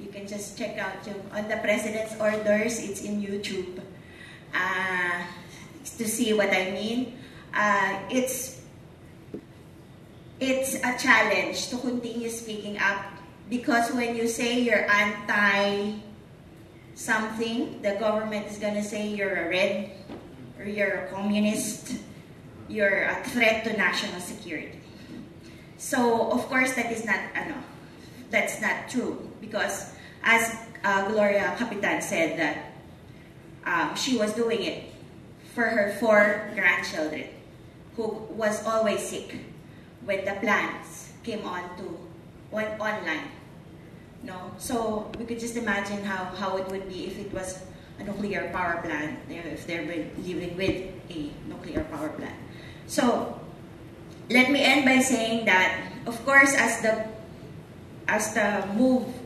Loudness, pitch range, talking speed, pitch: -26 LUFS, 190-230 Hz, 135 wpm, 210 Hz